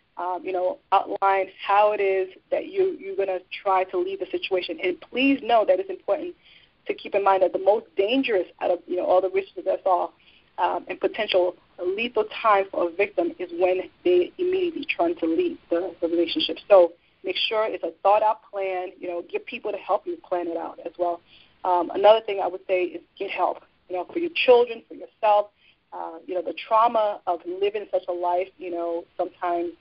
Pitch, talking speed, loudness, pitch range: 190 Hz, 215 wpm, -24 LUFS, 180-215 Hz